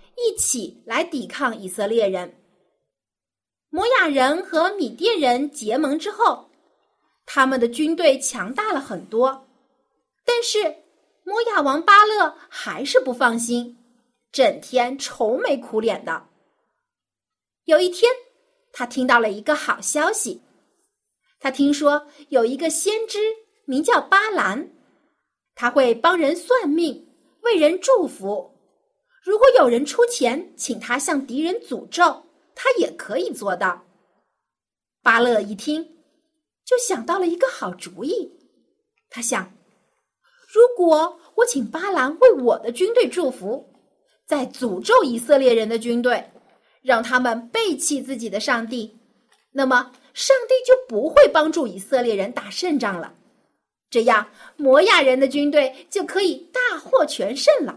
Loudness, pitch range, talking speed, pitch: -20 LUFS, 245-395 Hz, 190 characters per minute, 295 Hz